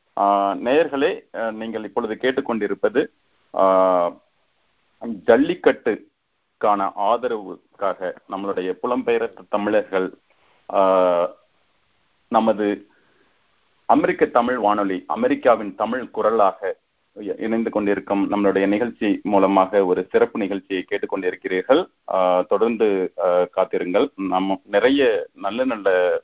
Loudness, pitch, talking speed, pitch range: -21 LUFS, 105 Hz, 75 wpm, 95-125 Hz